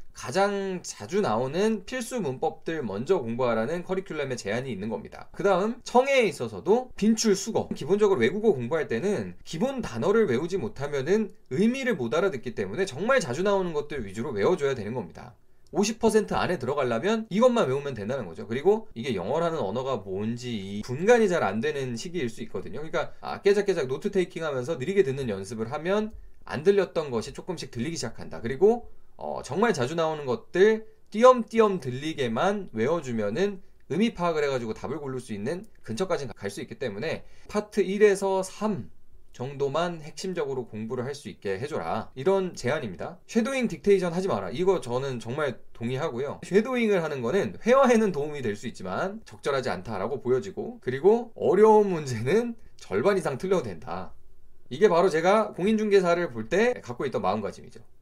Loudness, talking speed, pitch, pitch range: -27 LUFS, 385 characters per minute, 190 Hz, 130-210 Hz